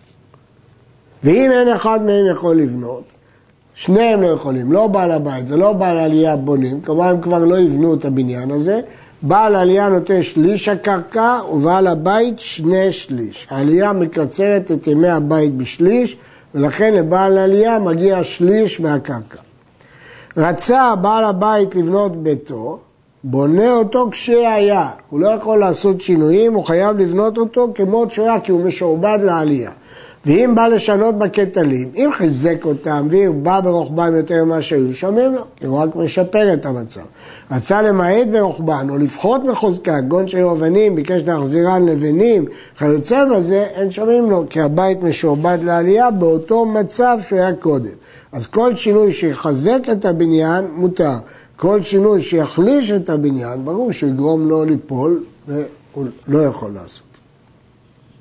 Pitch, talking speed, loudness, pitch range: 175 Hz, 140 wpm, -15 LUFS, 150-205 Hz